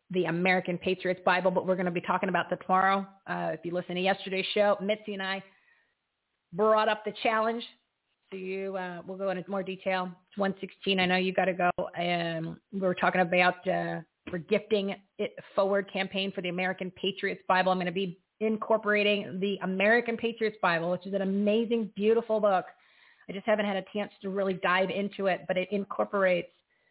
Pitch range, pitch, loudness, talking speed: 185-205 Hz, 190 Hz, -29 LUFS, 200 wpm